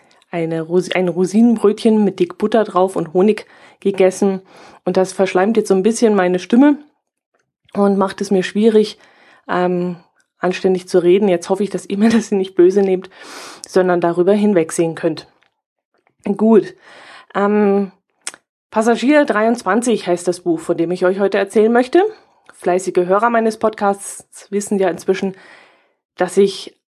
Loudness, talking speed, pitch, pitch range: -16 LUFS, 145 wpm, 195 Hz, 180-215 Hz